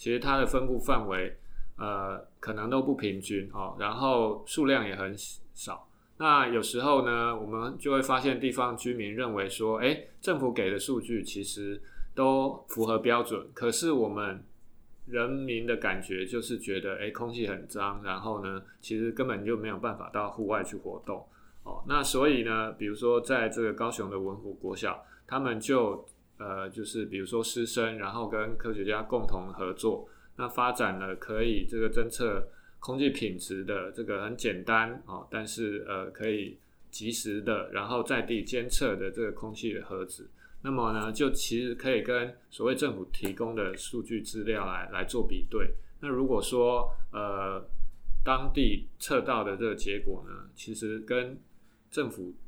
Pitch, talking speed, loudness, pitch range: 115 Hz, 250 characters per minute, -31 LUFS, 105-125 Hz